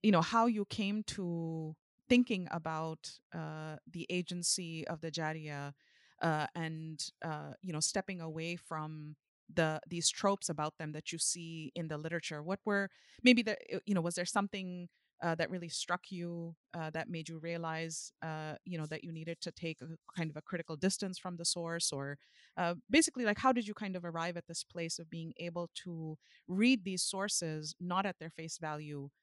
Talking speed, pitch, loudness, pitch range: 195 wpm, 170 Hz, -37 LUFS, 160-185 Hz